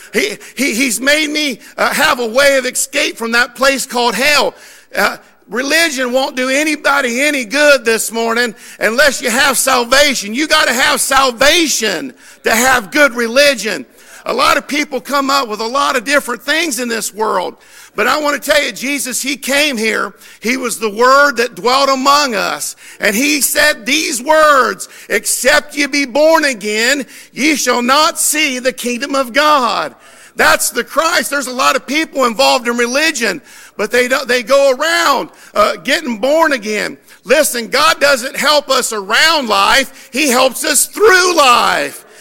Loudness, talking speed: -12 LUFS, 170 wpm